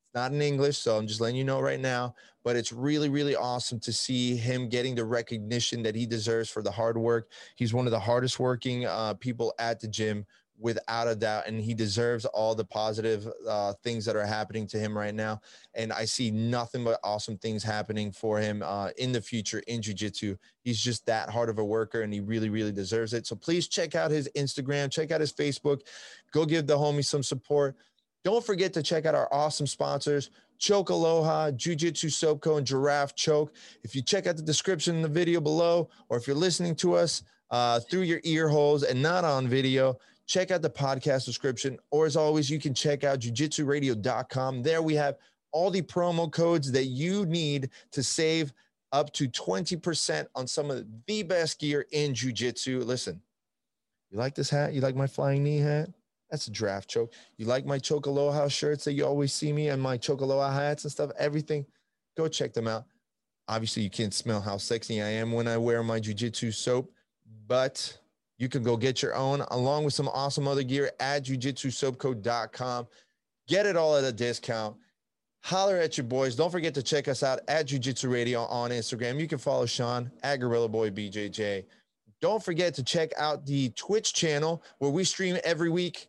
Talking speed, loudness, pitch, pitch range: 200 wpm, -29 LUFS, 135 Hz, 115-150 Hz